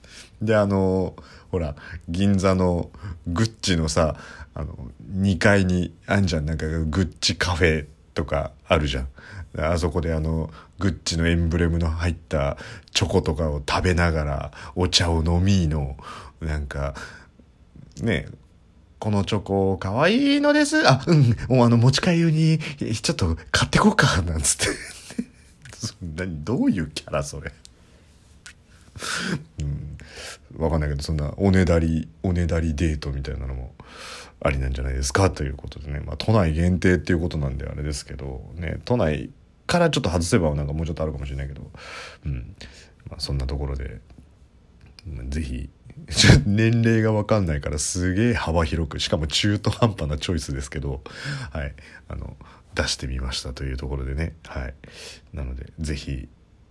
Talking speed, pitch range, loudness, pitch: 315 characters per minute, 75-100 Hz, -23 LUFS, 85 Hz